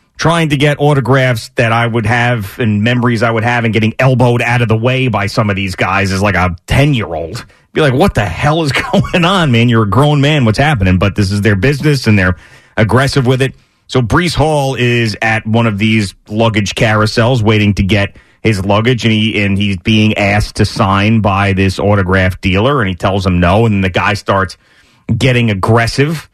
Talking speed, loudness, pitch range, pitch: 215 wpm, -11 LUFS, 100-130 Hz, 115 Hz